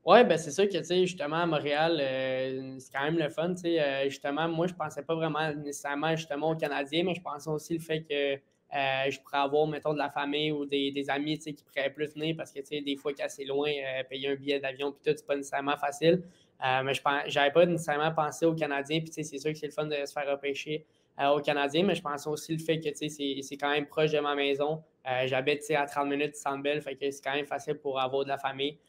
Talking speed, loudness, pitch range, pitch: 285 wpm, -30 LUFS, 140-155 Hz, 145 Hz